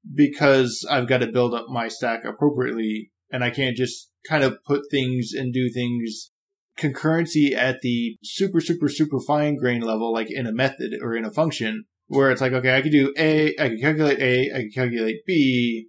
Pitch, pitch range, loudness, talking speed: 130 Hz, 115-145 Hz, -22 LUFS, 200 wpm